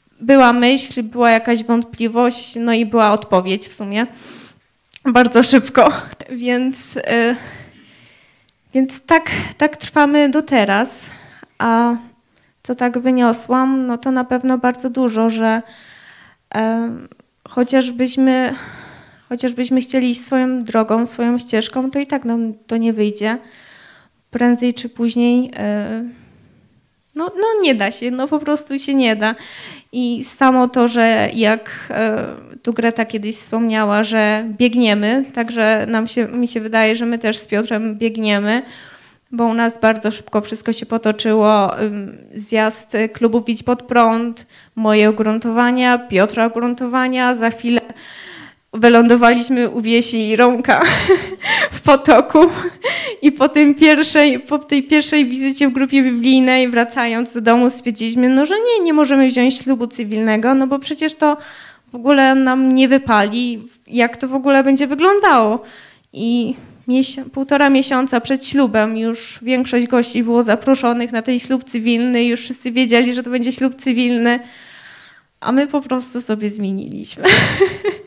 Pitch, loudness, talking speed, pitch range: 245 Hz, -15 LUFS, 135 wpm, 230-265 Hz